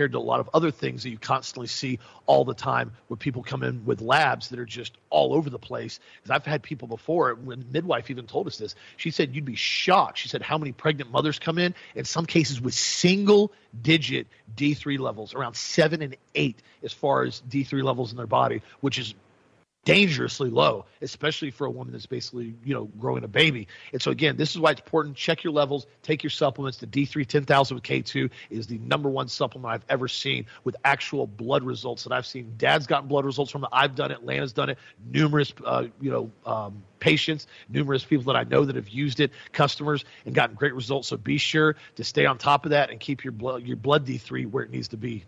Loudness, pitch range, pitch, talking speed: -25 LUFS, 120-150 Hz, 140 Hz, 230 wpm